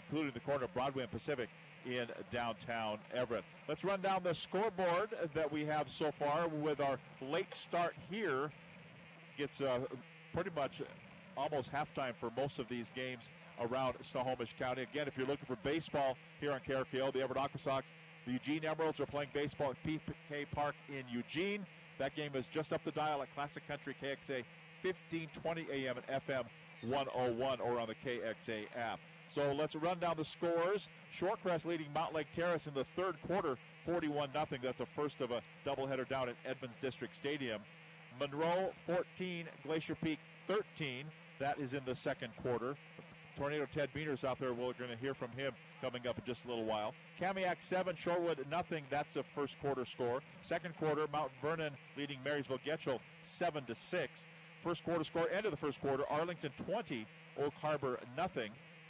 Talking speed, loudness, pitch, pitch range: 175 wpm, -40 LUFS, 150 Hz, 130-165 Hz